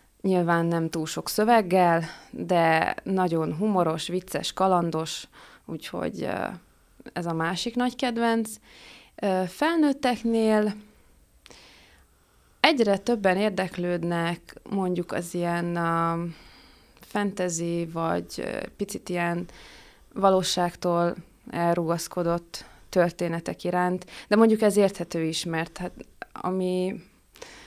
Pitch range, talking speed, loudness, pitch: 170-205 Hz, 85 wpm, -26 LUFS, 180 Hz